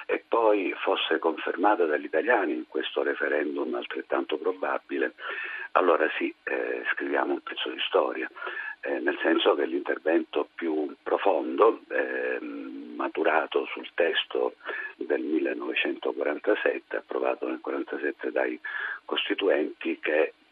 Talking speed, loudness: 110 wpm, -28 LUFS